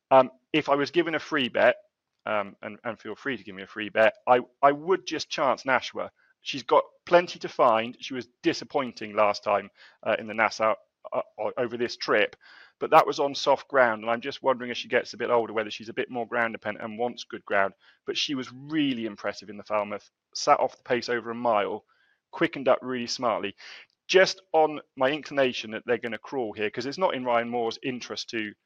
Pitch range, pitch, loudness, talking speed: 115-150 Hz, 125 Hz, -27 LUFS, 225 wpm